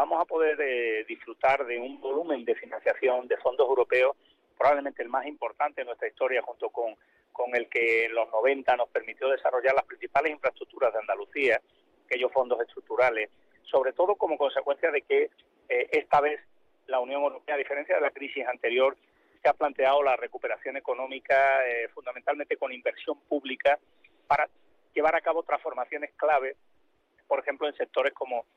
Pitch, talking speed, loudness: 150 Hz, 165 wpm, -28 LUFS